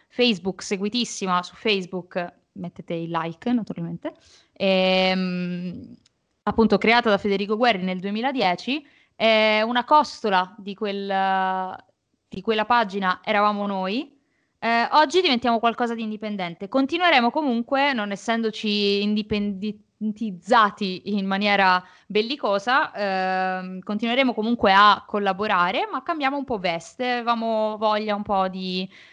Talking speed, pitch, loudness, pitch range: 115 wpm, 210 Hz, -22 LUFS, 190-235 Hz